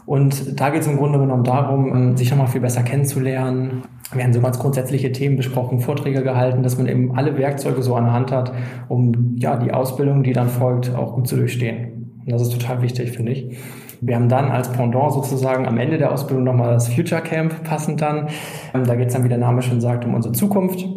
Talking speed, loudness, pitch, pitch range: 225 wpm, -19 LUFS, 130 Hz, 125-140 Hz